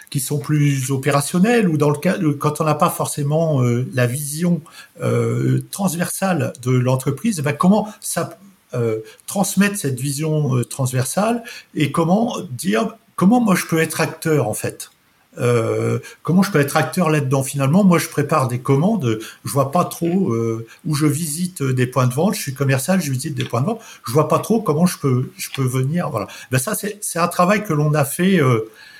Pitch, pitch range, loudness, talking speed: 150 Hz, 135-180 Hz, -19 LUFS, 200 wpm